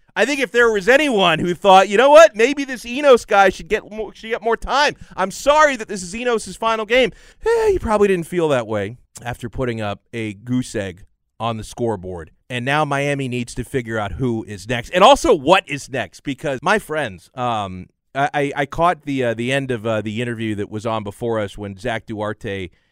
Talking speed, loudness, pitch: 220 wpm, -18 LUFS, 140 Hz